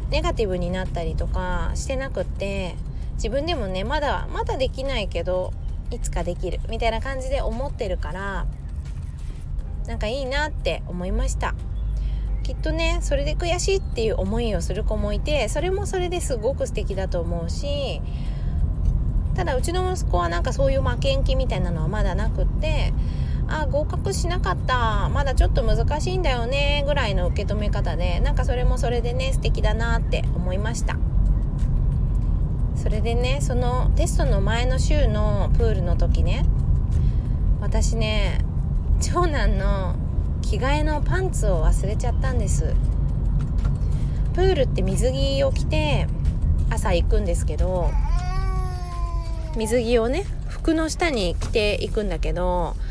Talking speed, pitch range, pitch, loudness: 300 characters per minute, 75-85 Hz, 75 Hz, -24 LUFS